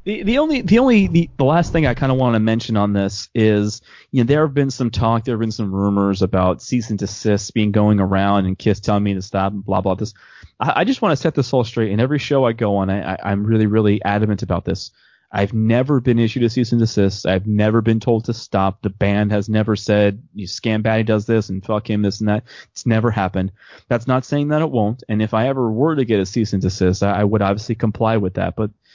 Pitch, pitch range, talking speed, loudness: 110 Hz, 100-120 Hz, 265 wpm, -18 LUFS